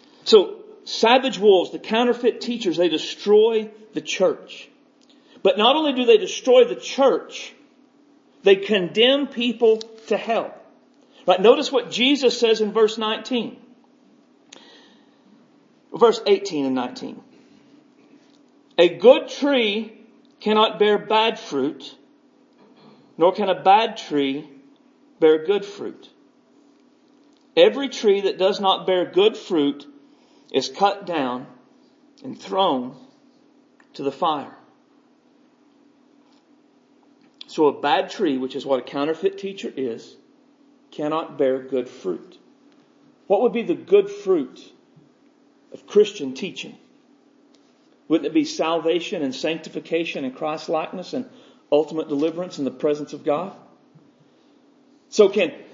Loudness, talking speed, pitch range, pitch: -20 LUFS, 115 wpm, 195-290 Hz, 255 Hz